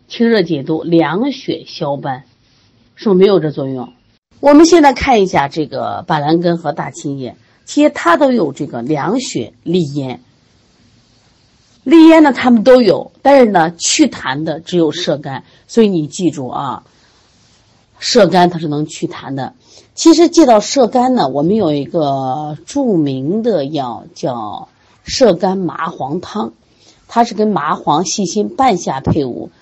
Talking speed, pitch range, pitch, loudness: 225 characters per minute, 140-235 Hz, 170 Hz, -13 LUFS